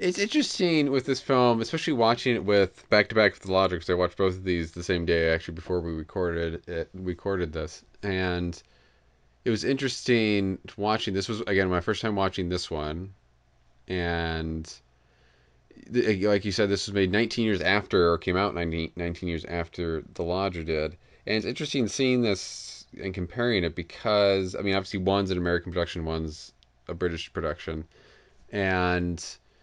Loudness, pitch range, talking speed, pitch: -27 LUFS, 85-105 Hz, 180 wpm, 90 Hz